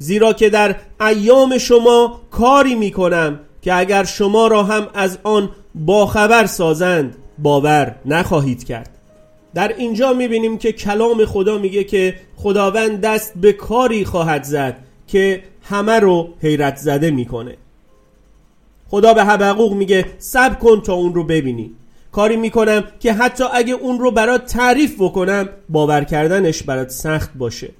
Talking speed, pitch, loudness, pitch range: 140 wpm, 200 Hz, -15 LUFS, 160-225 Hz